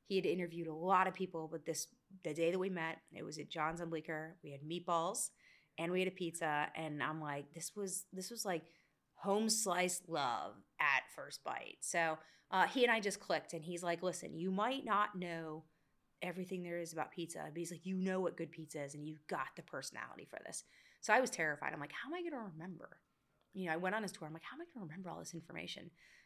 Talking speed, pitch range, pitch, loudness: 245 wpm, 160-190 Hz, 175 Hz, -40 LUFS